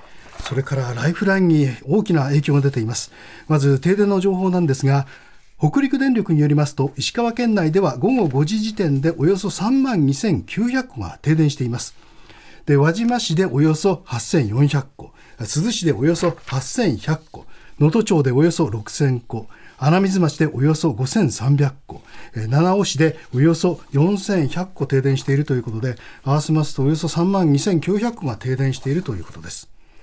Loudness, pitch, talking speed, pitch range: -19 LUFS, 155 Hz, 290 characters per minute, 135-180 Hz